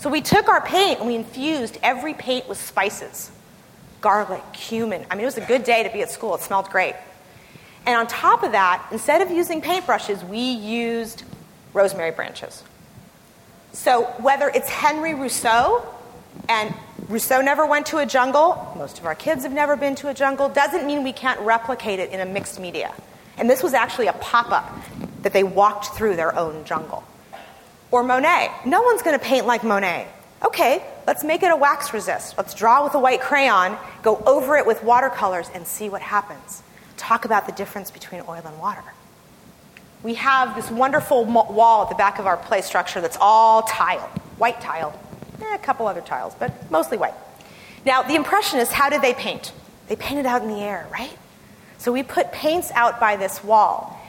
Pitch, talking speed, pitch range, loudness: 235 Hz, 190 wpm, 205-280 Hz, -20 LUFS